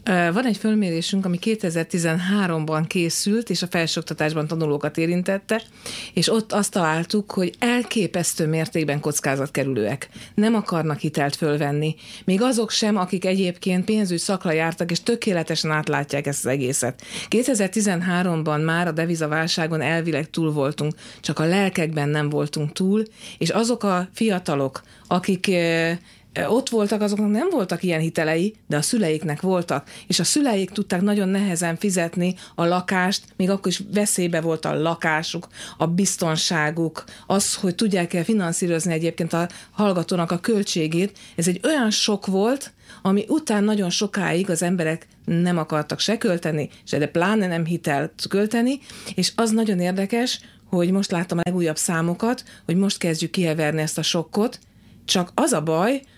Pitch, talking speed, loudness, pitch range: 175 Hz, 145 wpm, -22 LUFS, 160-205 Hz